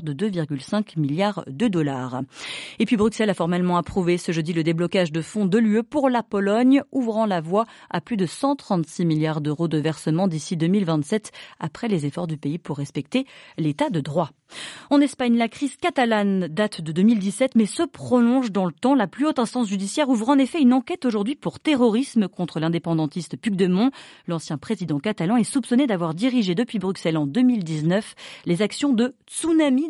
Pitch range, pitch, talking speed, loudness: 165-245 Hz, 200 Hz, 185 wpm, -22 LUFS